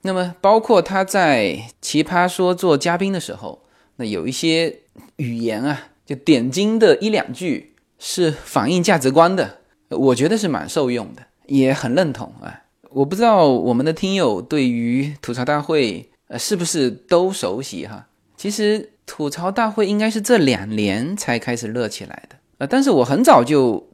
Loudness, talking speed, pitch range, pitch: -18 LUFS, 250 characters per minute, 135-200 Hz, 170 Hz